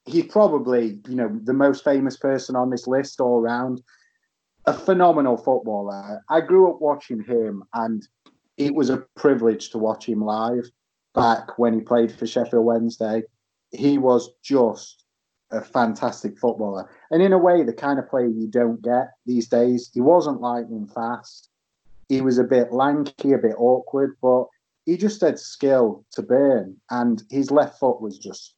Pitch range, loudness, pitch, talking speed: 115-140 Hz, -21 LUFS, 125 Hz, 170 wpm